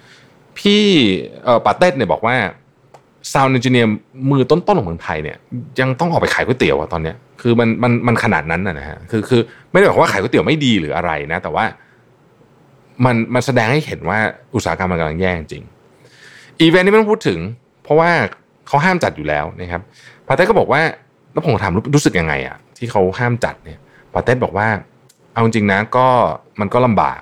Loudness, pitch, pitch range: -16 LUFS, 120 Hz, 95-140 Hz